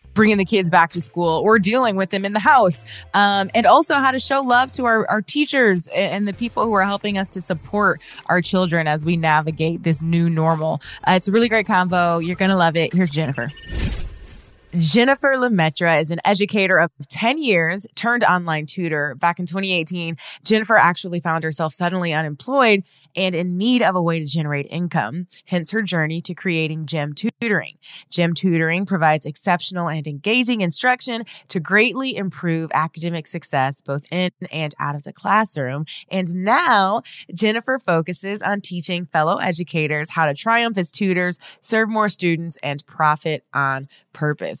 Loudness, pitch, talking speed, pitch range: -19 LUFS, 180 Hz, 175 wpm, 160-205 Hz